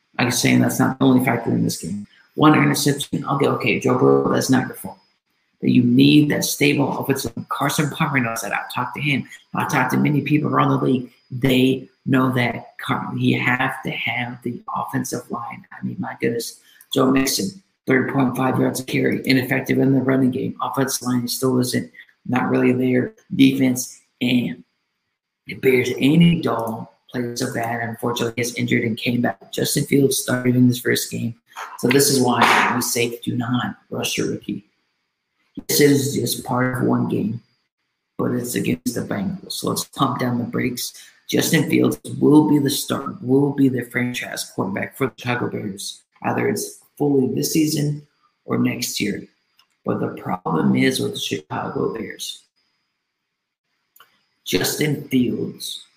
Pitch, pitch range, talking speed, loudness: 125 Hz, 120-140 Hz, 175 wpm, -20 LUFS